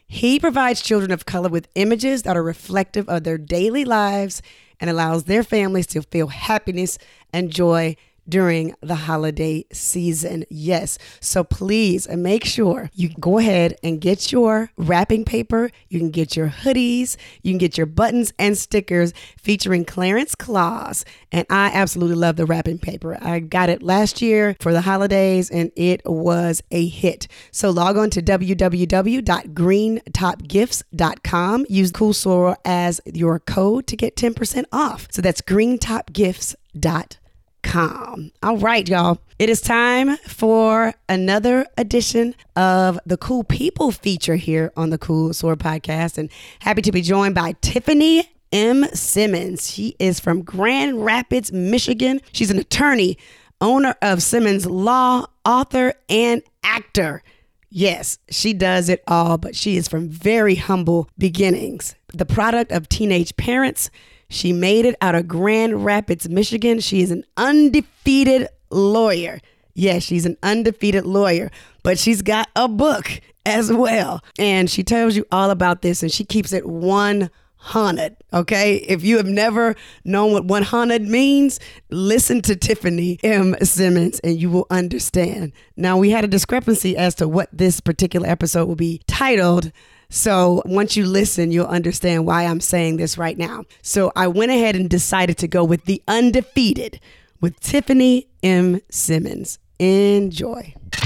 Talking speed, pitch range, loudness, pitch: 150 wpm, 175-220 Hz, -18 LUFS, 190 Hz